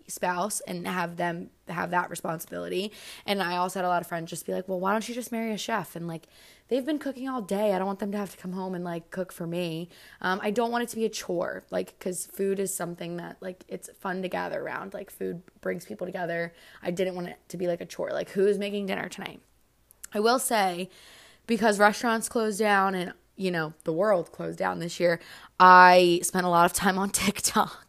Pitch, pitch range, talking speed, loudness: 185 Hz, 175-205 Hz, 240 wpm, -27 LUFS